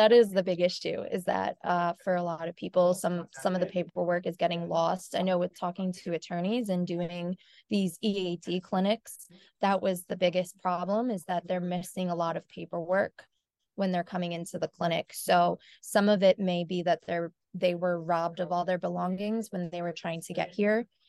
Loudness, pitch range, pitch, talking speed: -30 LUFS, 175-190 Hz, 180 Hz, 210 wpm